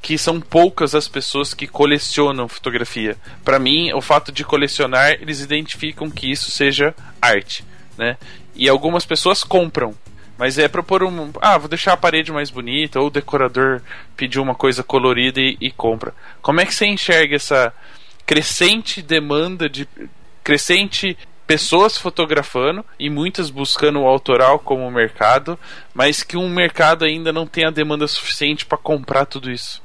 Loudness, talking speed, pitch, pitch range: -16 LUFS, 160 wpm, 145 Hz, 130-160 Hz